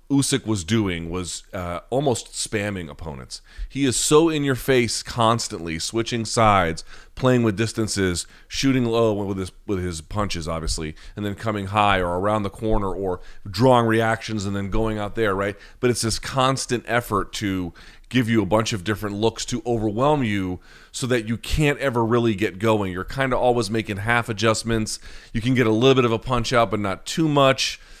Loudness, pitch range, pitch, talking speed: -22 LUFS, 100-120 Hz, 110 Hz, 195 wpm